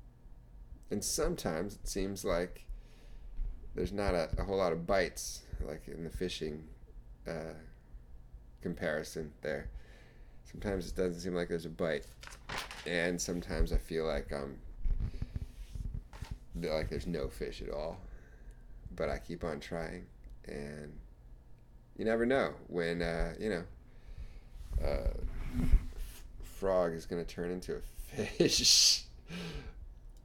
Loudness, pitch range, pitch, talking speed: -35 LUFS, 65-90 Hz, 80 Hz, 125 wpm